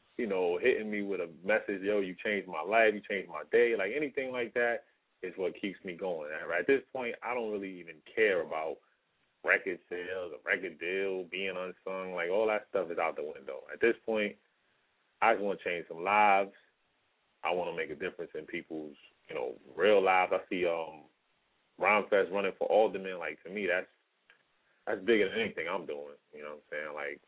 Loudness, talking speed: -32 LUFS, 215 wpm